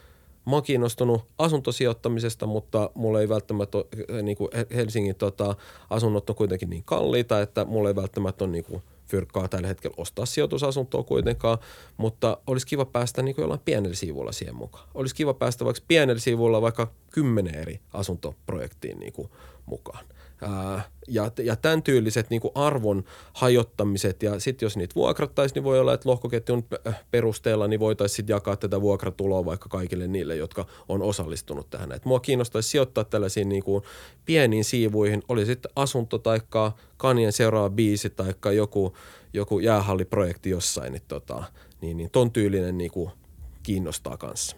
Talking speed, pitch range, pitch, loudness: 150 wpm, 95-120 Hz, 105 Hz, -26 LUFS